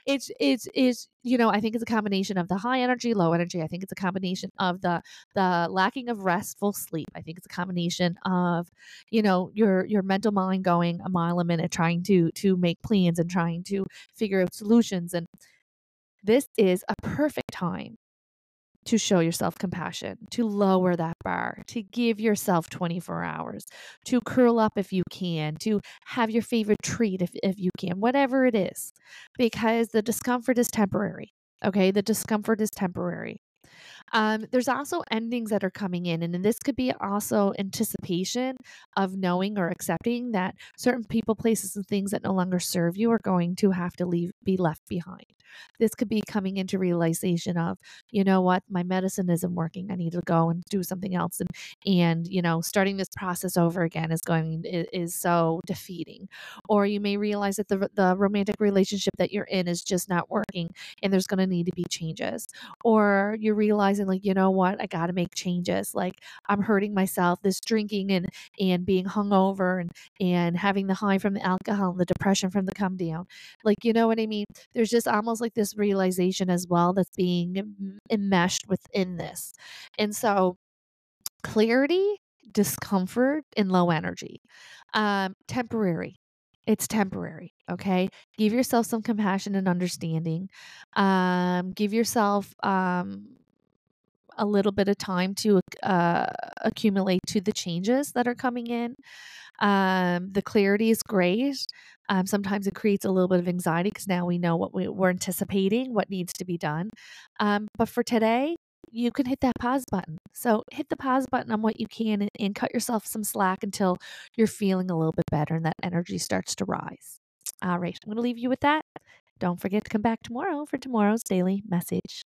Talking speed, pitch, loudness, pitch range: 185 wpm, 195 Hz, -26 LUFS, 180-220 Hz